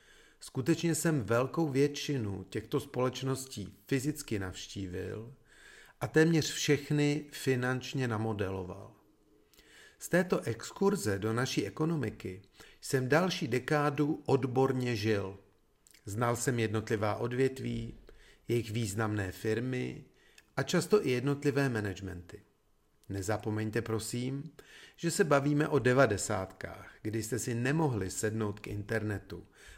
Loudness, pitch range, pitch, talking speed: -32 LUFS, 110-145 Hz, 125 Hz, 100 wpm